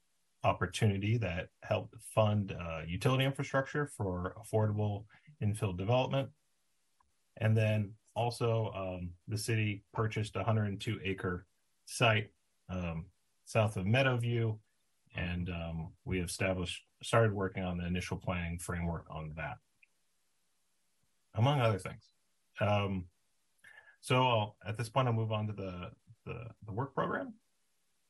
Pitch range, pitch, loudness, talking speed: 95-115 Hz, 105 Hz, -35 LUFS, 120 wpm